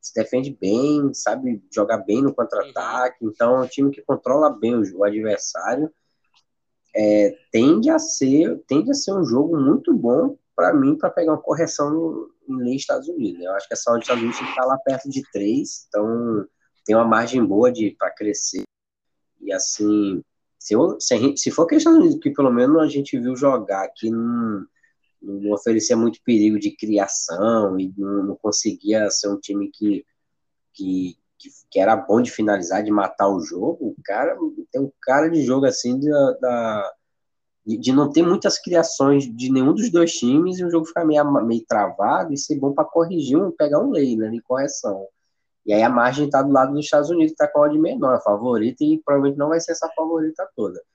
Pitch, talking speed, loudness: 140 Hz, 200 wpm, -20 LUFS